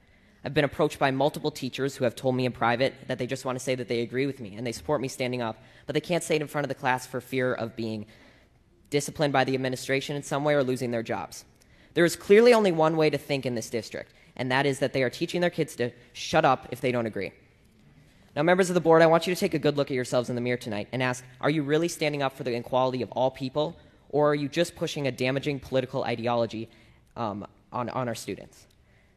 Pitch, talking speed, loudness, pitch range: 130 Hz, 260 wpm, -27 LUFS, 125-150 Hz